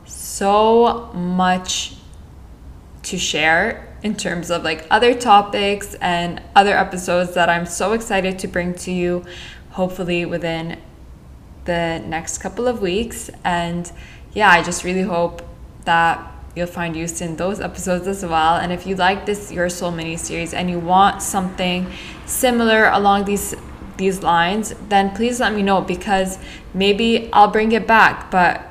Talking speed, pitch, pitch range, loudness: 155 wpm, 185 Hz, 170-200 Hz, -18 LUFS